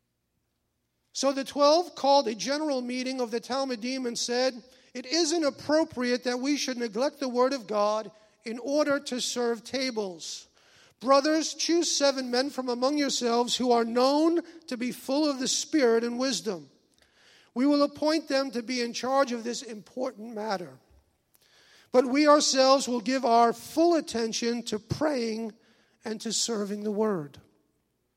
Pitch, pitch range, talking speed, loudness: 250 Hz, 230-275 Hz, 155 wpm, -27 LUFS